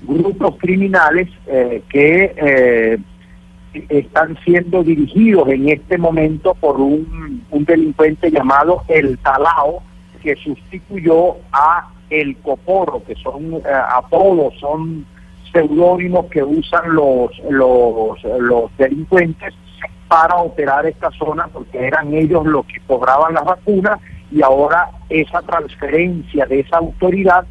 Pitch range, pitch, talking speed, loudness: 135-175 Hz, 155 Hz, 120 wpm, -14 LUFS